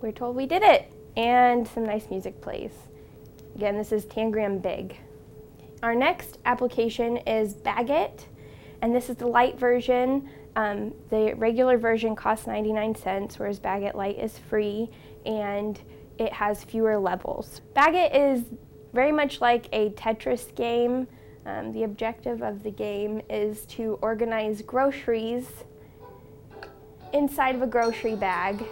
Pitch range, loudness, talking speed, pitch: 215-245 Hz, -26 LUFS, 140 wpm, 225 Hz